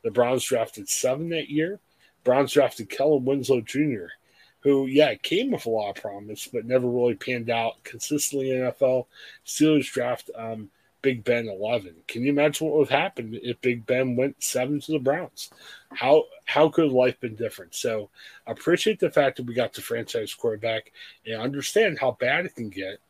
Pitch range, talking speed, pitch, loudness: 120-150 Hz, 185 wpm, 135 Hz, -25 LUFS